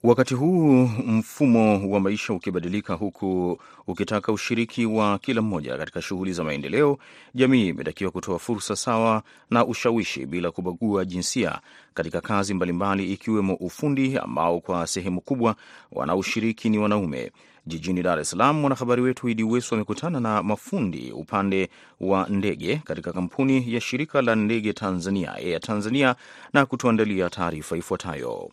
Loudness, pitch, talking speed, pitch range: -24 LUFS, 105 Hz, 135 wpm, 95-120 Hz